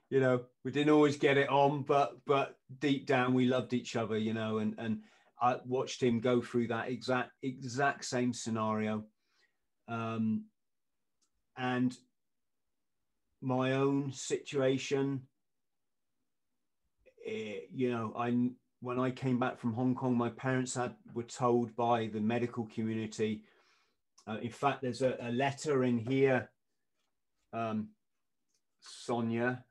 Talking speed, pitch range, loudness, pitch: 135 wpm, 115-130 Hz, -33 LUFS, 125 Hz